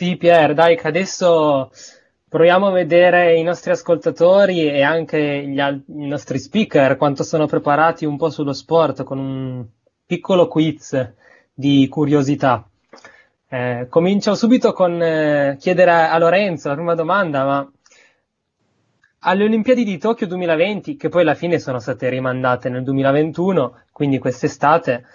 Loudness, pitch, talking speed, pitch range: -17 LUFS, 155 Hz, 145 wpm, 140-175 Hz